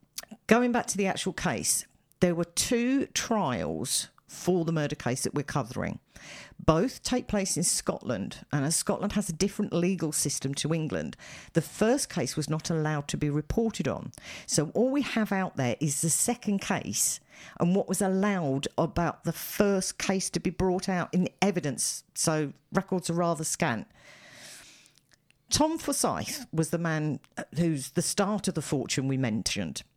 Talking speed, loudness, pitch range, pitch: 170 wpm, -28 LUFS, 155-200 Hz, 175 Hz